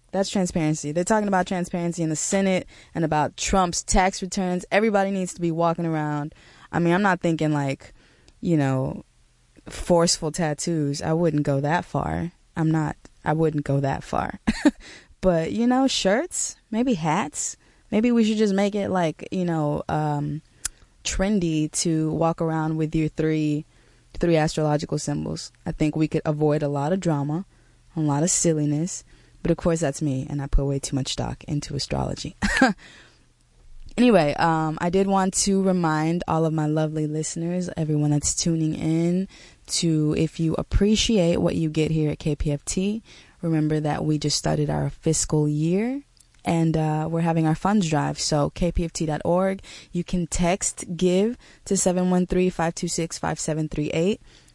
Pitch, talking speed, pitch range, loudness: 160 Hz, 170 wpm, 150-185 Hz, -23 LUFS